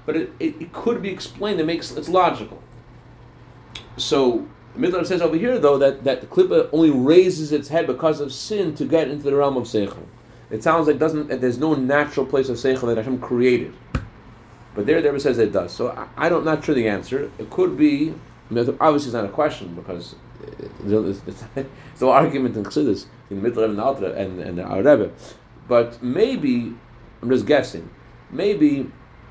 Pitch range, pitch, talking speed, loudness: 120-165 Hz, 140 Hz, 190 wpm, -20 LUFS